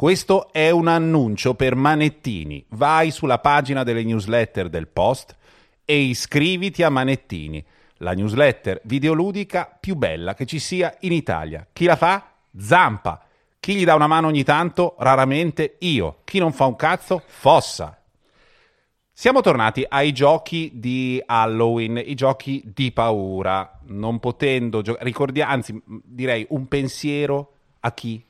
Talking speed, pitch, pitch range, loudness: 140 wpm, 135 Hz, 115-155 Hz, -20 LUFS